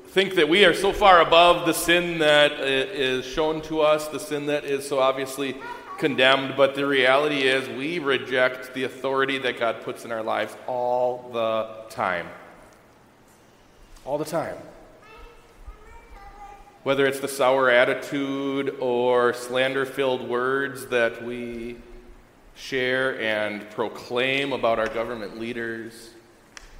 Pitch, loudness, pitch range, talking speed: 130 Hz, -22 LUFS, 120-150 Hz, 130 wpm